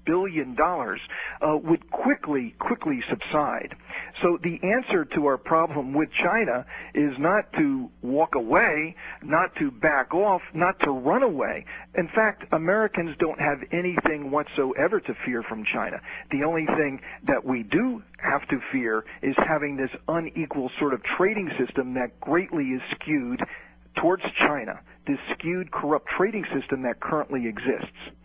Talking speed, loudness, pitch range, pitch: 150 wpm, -25 LUFS, 140-185 Hz, 160 Hz